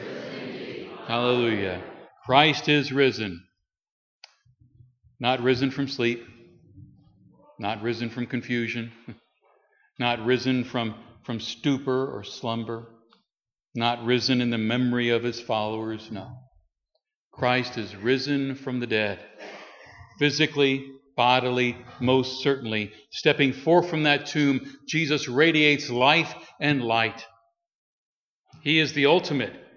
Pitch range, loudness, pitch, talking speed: 115-140 Hz, -24 LUFS, 125 Hz, 105 wpm